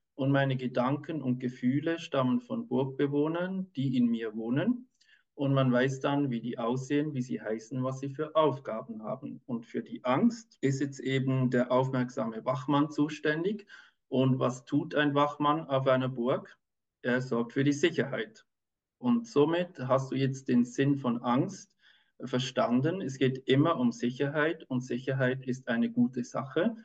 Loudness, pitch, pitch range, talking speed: -30 LUFS, 135 Hz, 125-150 Hz, 160 wpm